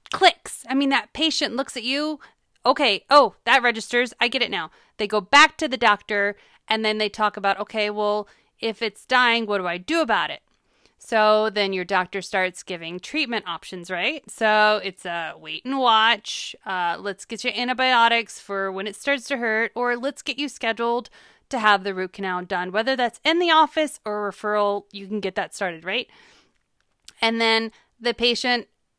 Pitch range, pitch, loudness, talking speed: 200-255 Hz, 225 Hz, -22 LUFS, 195 wpm